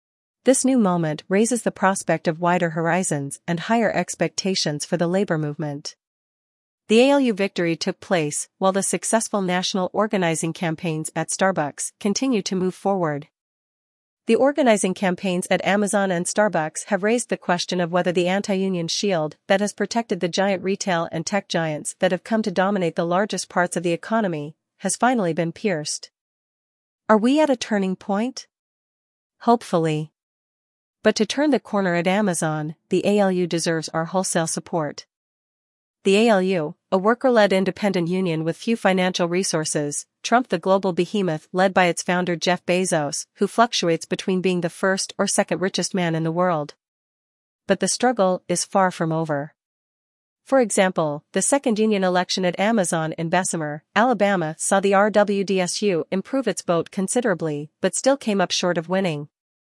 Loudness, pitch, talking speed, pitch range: -21 LUFS, 185 Hz, 160 wpm, 170-200 Hz